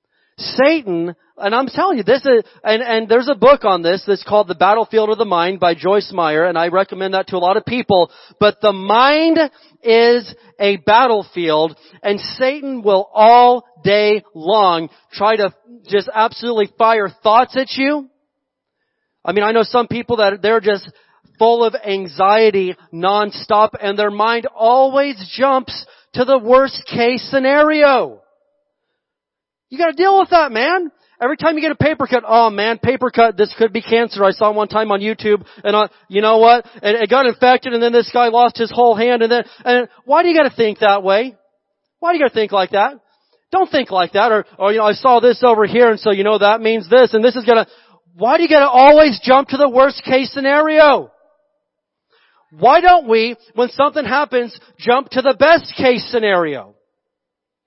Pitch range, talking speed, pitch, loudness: 205-270 Hz, 195 wpm, 230 Hz, -14 LUFS